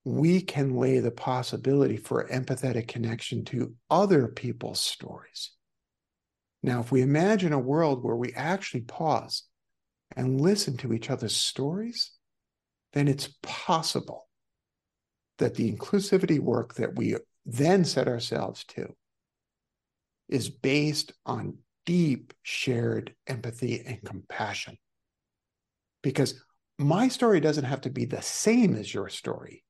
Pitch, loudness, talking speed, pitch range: 130 Hz, -28 LUFS, 125 wpm, 120-150 Hz